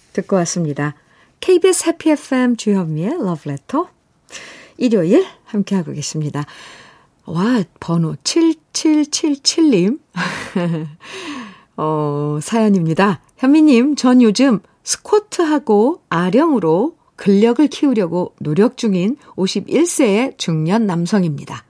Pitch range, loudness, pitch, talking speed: 170-285 Hz, -16 LUFS, 215 Hz, 235 characters per minute